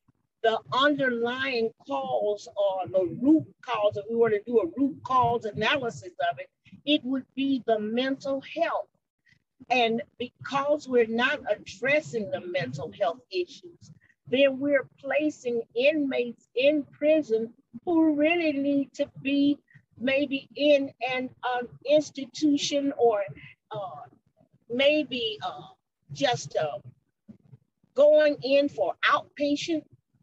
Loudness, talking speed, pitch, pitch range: -26 LUFS, 115 wpm, 255 Hz, 215-290 Hz